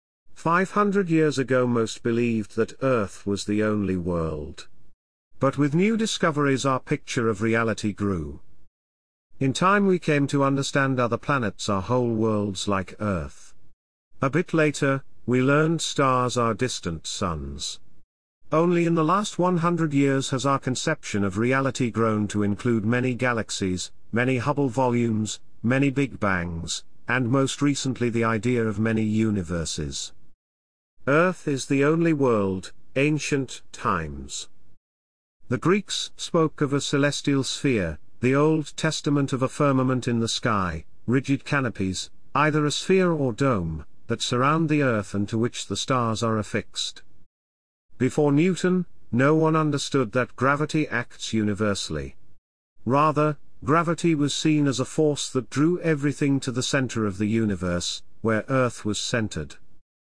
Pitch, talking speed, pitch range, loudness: 125 Hz, 140 wpm, 100-145 Hz, -24 LUFS